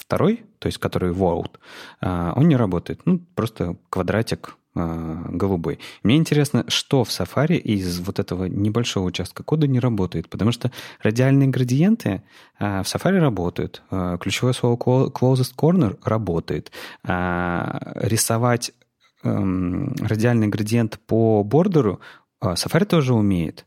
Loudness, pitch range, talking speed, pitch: -21 LUFS, 95-135 Hz, 115 wpm, 115 Hz